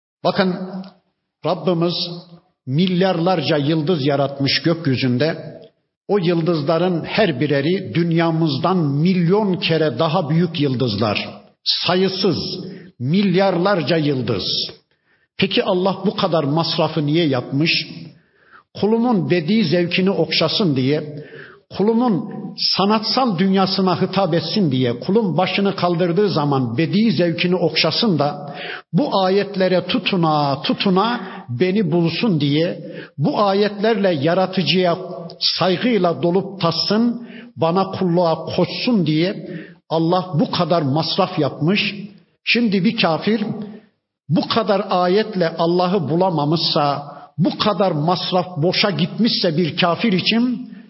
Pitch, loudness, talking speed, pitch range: 180 Hz, -18 LUFS, 100 wpm, 165-195 Hz